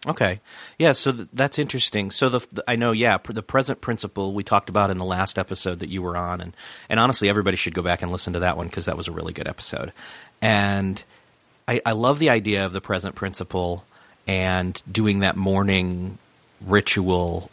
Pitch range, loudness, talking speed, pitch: 90-115 Hz, -22 LUFS, 210 wpm, 100 Hz